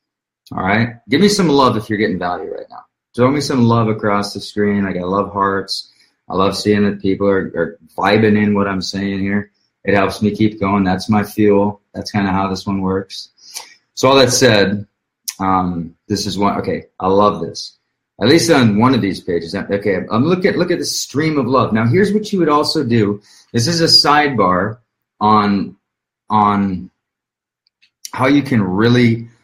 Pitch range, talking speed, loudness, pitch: 100-120 Hz, 200 wpm, -15 LUFS, 105 Hz